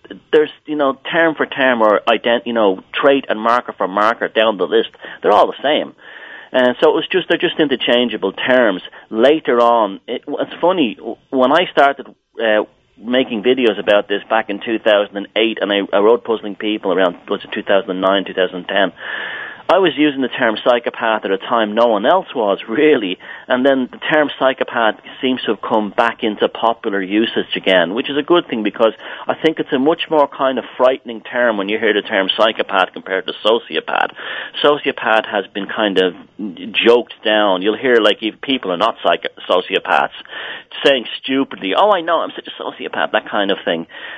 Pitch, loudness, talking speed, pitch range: 120 Hz, -16 LUFS, 200 wpm, 105-140 Hz